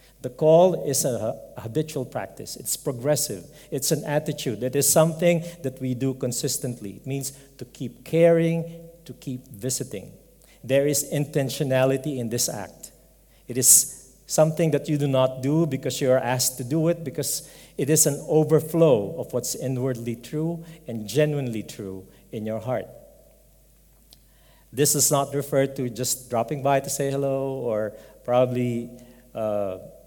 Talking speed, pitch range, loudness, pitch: 150 wpm, 125-150 Hz, -23 LUFS, 135 Hz